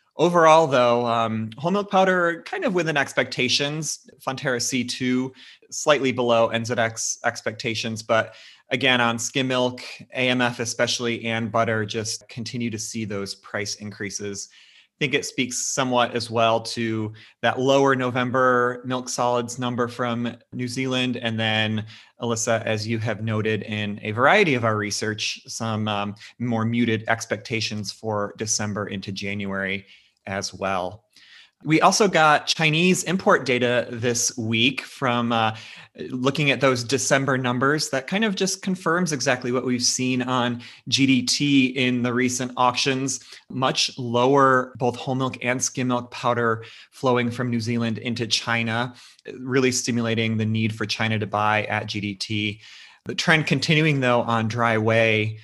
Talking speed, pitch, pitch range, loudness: 145 wpm, 120 Hz, 110-130 Hz, -22 LUFS